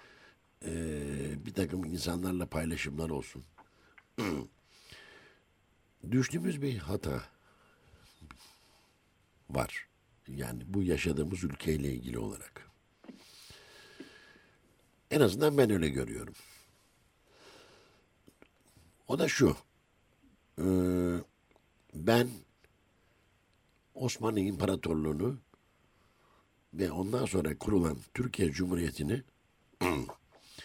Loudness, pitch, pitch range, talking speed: -33 LUFS, 90 Hz, 75-105 Hz, 65 wpm